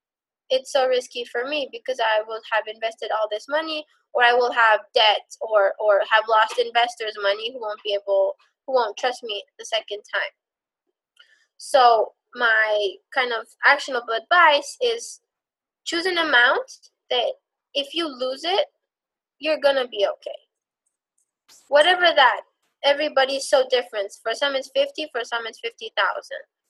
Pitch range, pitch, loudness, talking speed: 220-305 Hz, 260 Hz, -21 LUFS, 155 wpm